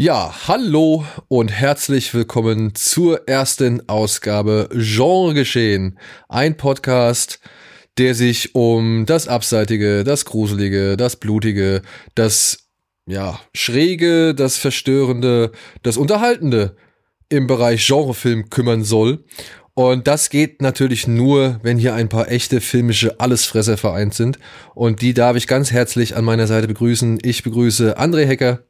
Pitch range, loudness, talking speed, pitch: 110-135 Hz, -16 LUFS, 125 wpm, 120 Hz